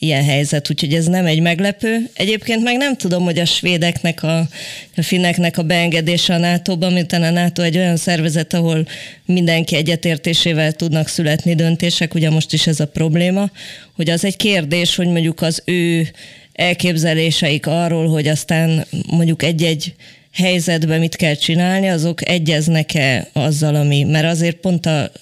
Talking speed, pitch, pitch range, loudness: 155 wpm, 170 Hz, 160-175 Hz, -16 LUFS